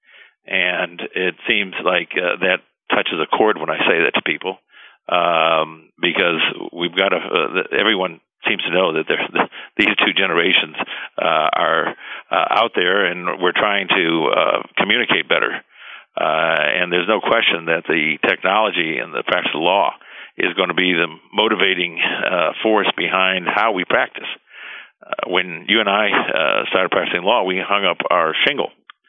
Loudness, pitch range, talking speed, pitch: -17 LUFS, 85-95 Hz, 170 wpm, 90 Hz